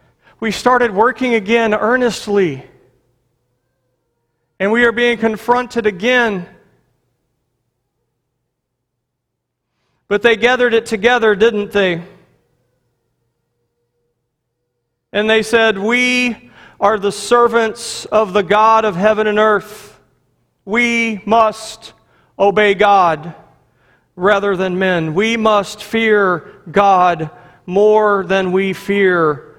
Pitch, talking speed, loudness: 200 Hz, 95 wpm, -14 LUFS